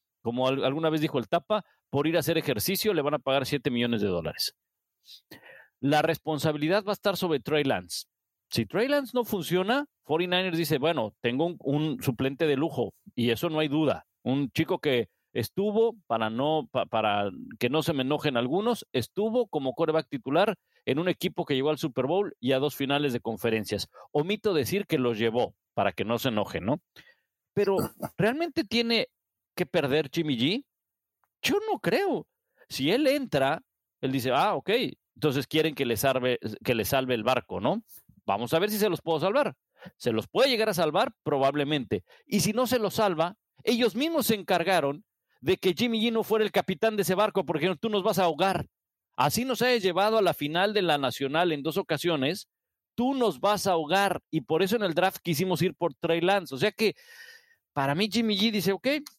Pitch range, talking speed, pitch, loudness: 140-210 Hz, 200 wpm, 165 Hz, -27 LUFS